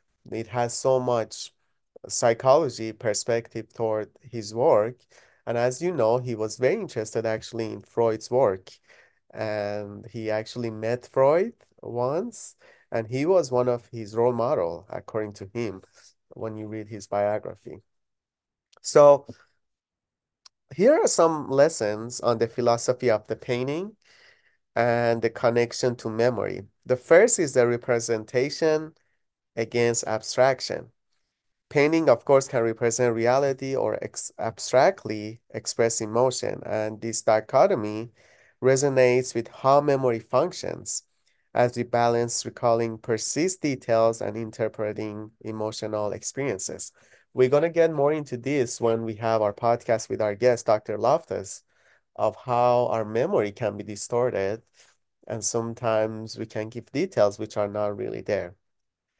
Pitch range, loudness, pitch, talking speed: 110-125 Hz, -25 LUFS, 115 Hz, 130 wpm